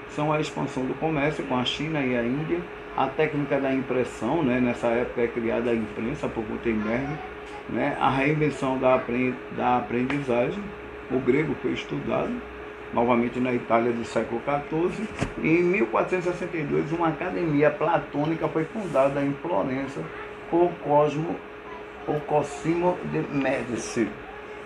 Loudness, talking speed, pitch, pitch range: -26 LUFS, 135 wpm, 140 Hz, 125-155 Hz